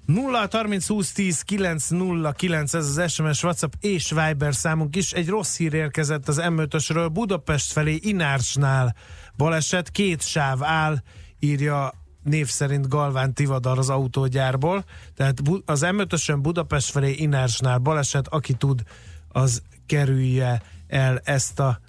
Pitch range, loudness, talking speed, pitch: 135-165 Hz, -23 LUFS, 135 wpm, 150 Hz